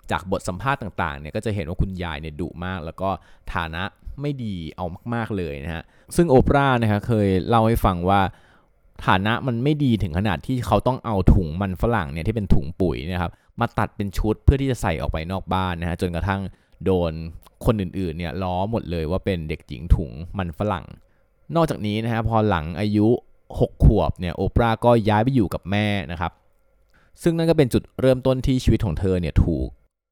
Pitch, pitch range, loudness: 95 Hz, 85-115 Hz, -23 LUFS